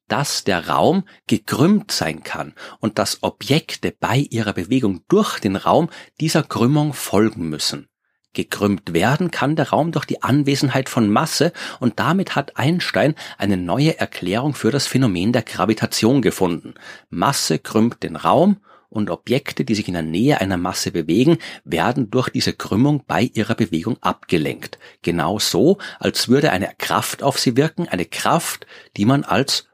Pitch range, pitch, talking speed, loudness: 100-140 Hz, 120 Hz, 155 wpm, -19 LUFS